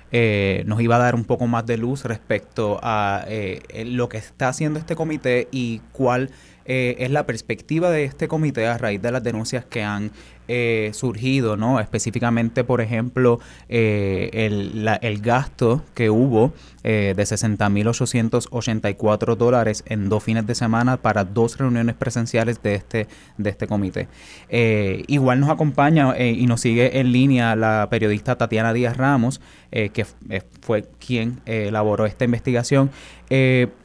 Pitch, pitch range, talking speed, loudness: 115 Hz, 110-125 Hz, 165 wpm, -21 LUFS